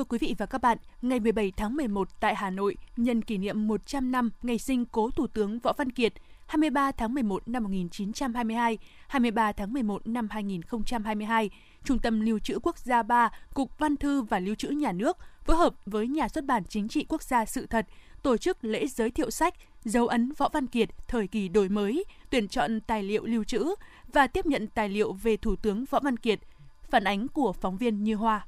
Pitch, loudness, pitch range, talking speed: 230 Hz, -29 LUFS, 215-265 Hz, 215 wpm